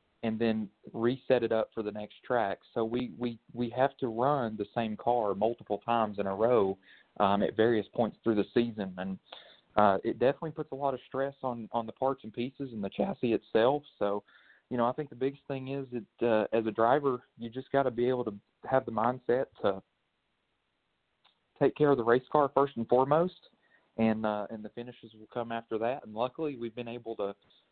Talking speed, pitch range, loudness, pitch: 215 wpm, 110-130 Hz, -31 LUFS, 120 Hz